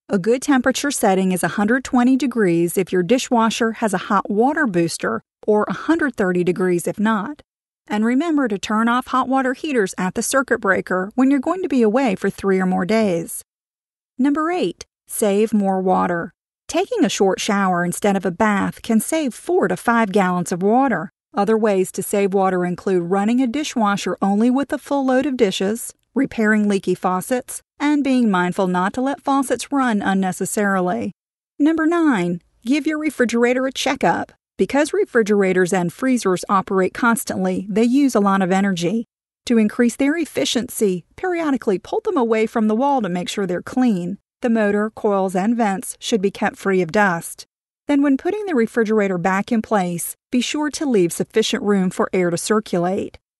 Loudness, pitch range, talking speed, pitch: -19 LUFS, 190-260 Hz, 175 wpm, 220 Hz